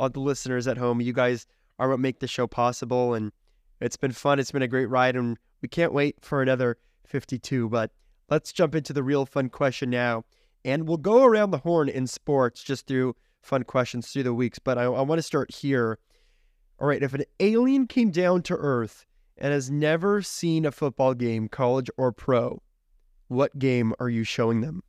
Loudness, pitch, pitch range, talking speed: -25 LUFS, 130 Hz, 125-145 Hz, 205 wpm